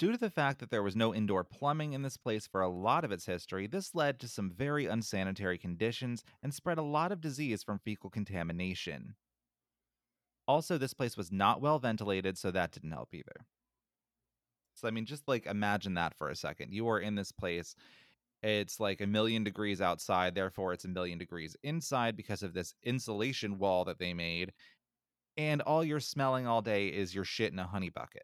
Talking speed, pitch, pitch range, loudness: 200 wpm, 105 Hz, 90-130 Hz, -35 LUFS